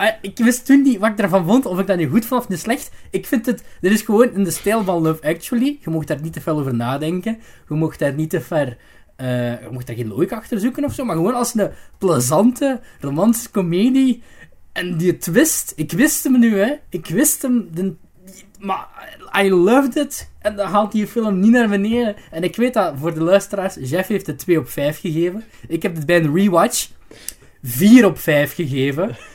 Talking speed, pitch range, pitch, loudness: 220 wpm, 165-235 Hz, 195 Hz, -18 LUFS